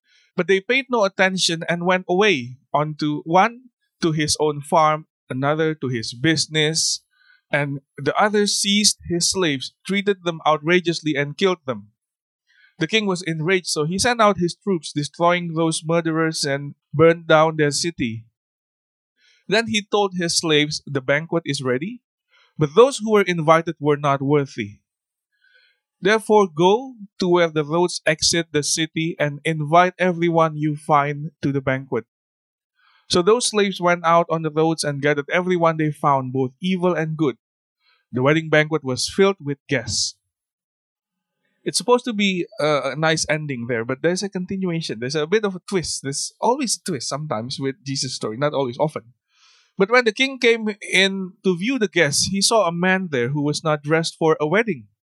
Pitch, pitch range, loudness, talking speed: 165 Hz, 145-190 Hz, -20 LUFS, 170 wpm